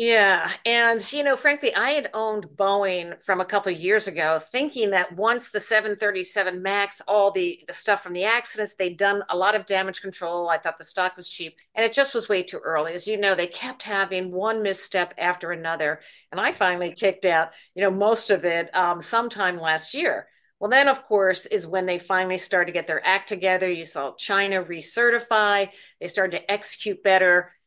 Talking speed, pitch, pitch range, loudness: 205 wpm, 195 Hz, 180-215 Hz, -23 LUFS